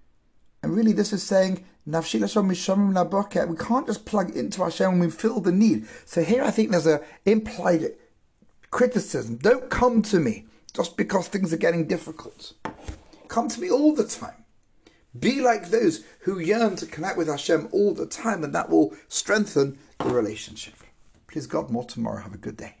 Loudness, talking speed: -24 LUFS, 175 wpm